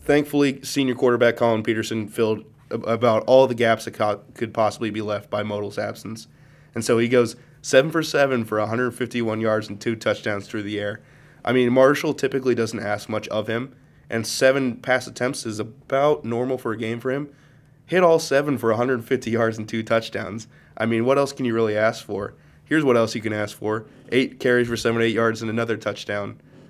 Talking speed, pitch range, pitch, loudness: 200 wpm, 110-130 Hz, 115 Hz, -22 LUFS